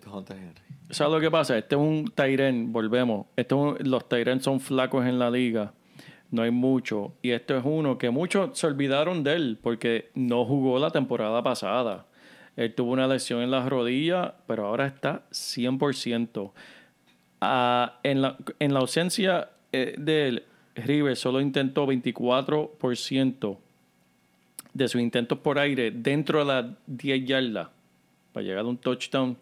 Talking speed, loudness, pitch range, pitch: 155 wpm, -26 LUFS, 120-140 Hz, 130 Hz